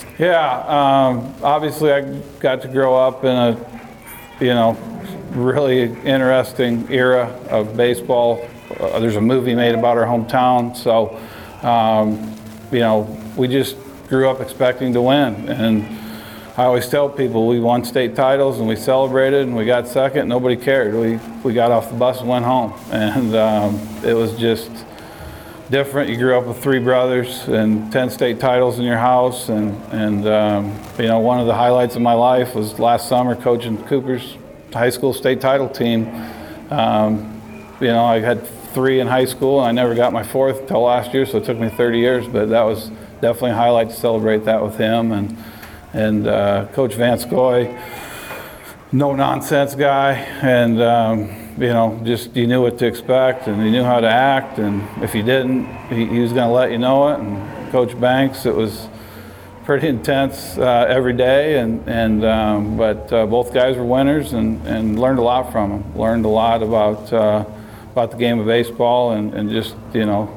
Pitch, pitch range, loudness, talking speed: 120 Hz, 110-130 Hz, -17 LUFS, 185 wpm